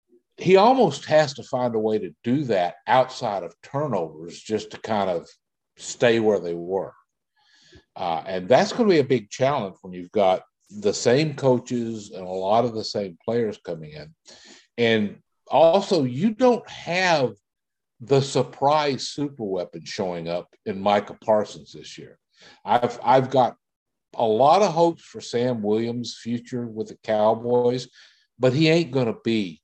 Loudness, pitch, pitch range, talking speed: -22 LUFS, 120 Hz, 110-150 Hz, 165 wpm